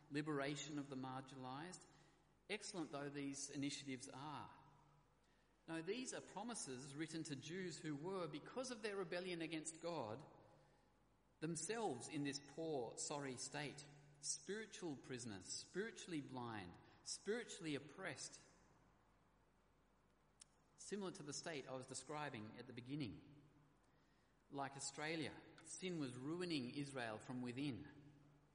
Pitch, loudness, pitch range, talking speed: 145 Hz, -50 LUFS, 140-165 Hz, 115 wpm